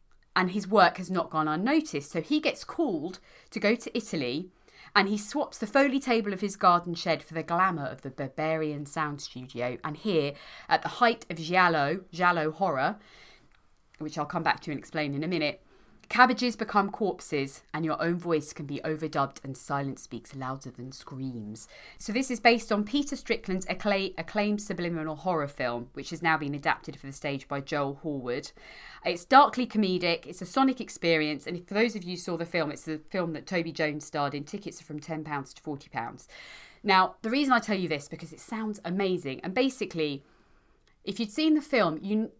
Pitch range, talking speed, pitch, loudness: 150-210 Hz, 200 wpm, 170 Hz, -28 LUFS